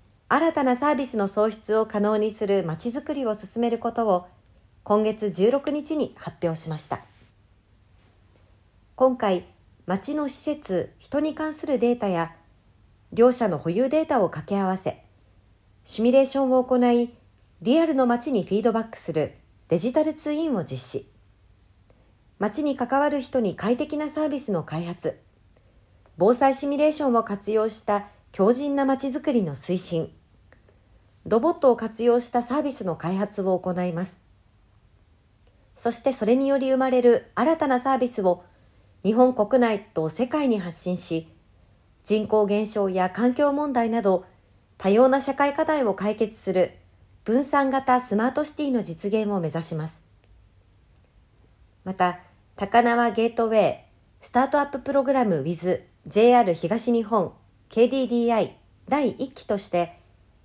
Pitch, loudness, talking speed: 210 Hz, -24 LUFS, 280 characters per minute